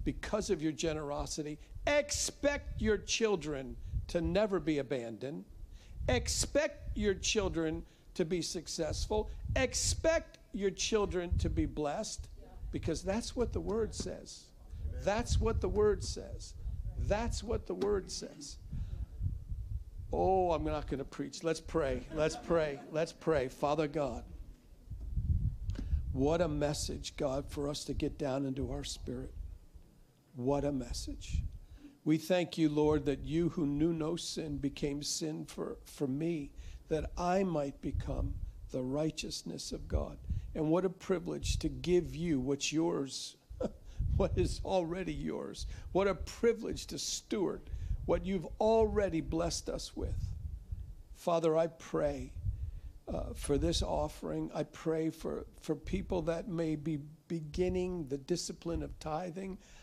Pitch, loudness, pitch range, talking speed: 155 Hz, -36 LUFS, 125-175 Hz, 140 wpm